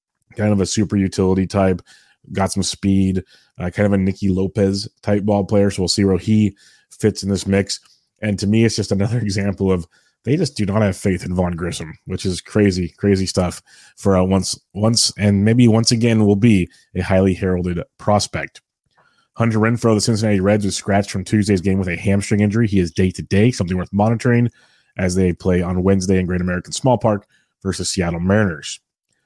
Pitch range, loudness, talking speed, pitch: 95-105 Hz, -18 LUFS, 205 wpm, 100 Hz